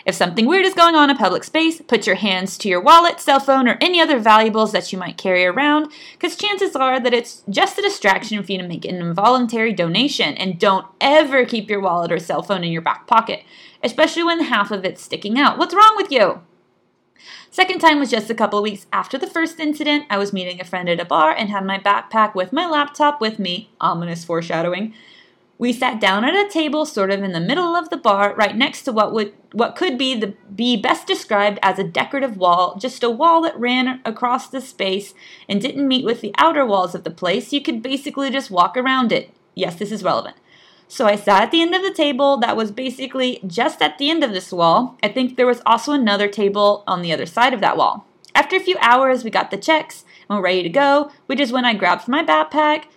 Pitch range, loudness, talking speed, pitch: 195-290 Hz, -17 LUFS, 235 wpm, 235 Hz